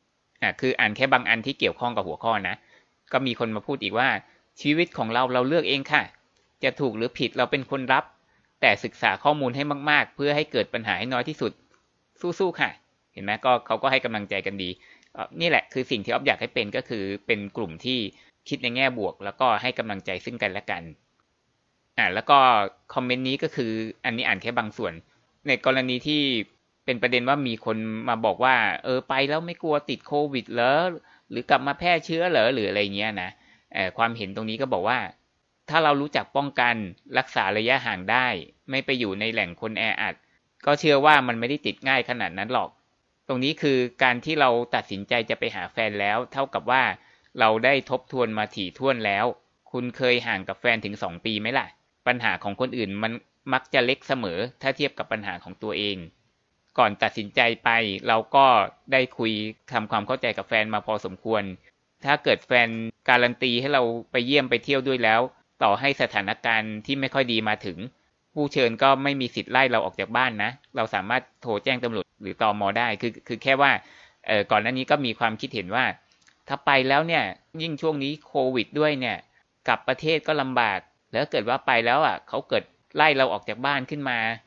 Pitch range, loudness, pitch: 110-140 Hz, -24 LUFS, 125 Hz